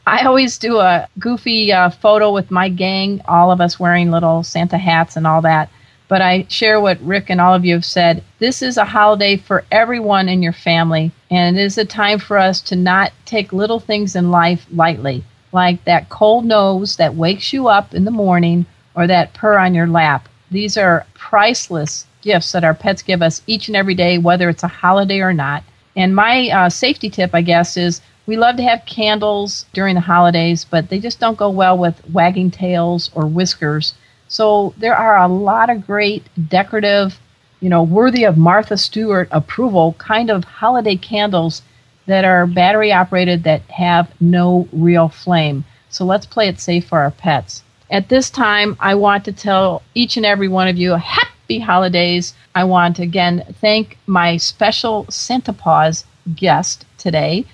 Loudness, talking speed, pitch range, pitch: -14 LUFS, 190 wpm, 170-205 Hz, 185 Hz